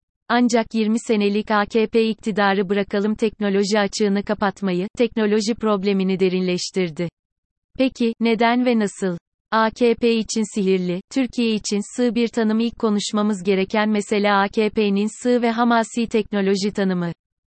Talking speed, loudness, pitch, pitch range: 115 wpm, -20 LUFS, 210 Hz, 200-230 Hz